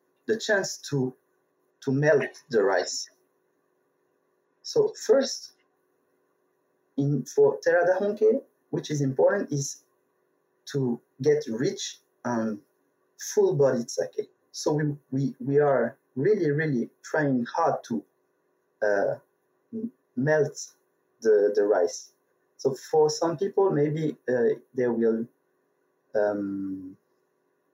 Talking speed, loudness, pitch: 100 wpm, -26 LUFS, 155 Hz